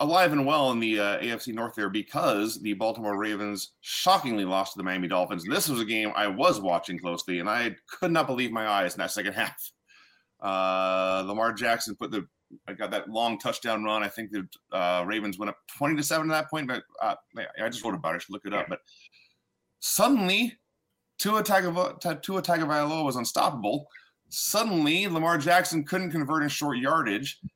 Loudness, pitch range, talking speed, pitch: -27 LUFS, 105-160 Hz, 200 wpm, 115 Hz